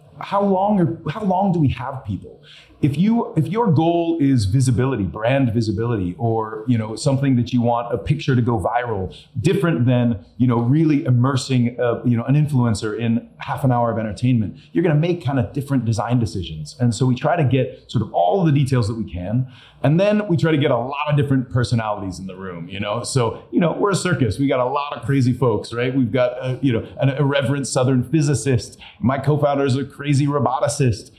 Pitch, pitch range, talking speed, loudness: 130 Hz, 120-145 Hz, 220 wpm, -20 LUFS